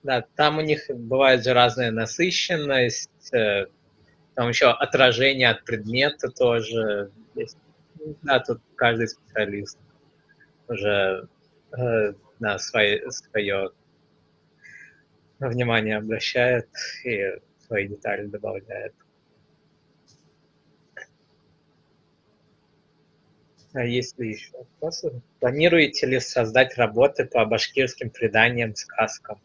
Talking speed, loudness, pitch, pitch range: 85 wpm, -23 LUFS, 120 Hz, 110-135 Hz